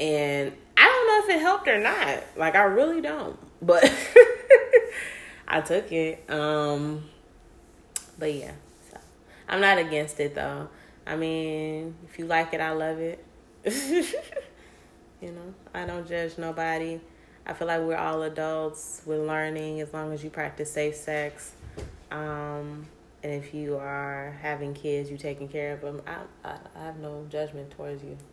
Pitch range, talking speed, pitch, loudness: 150-165 Hz, 160 wpm, 155 Hz, -24 LUFS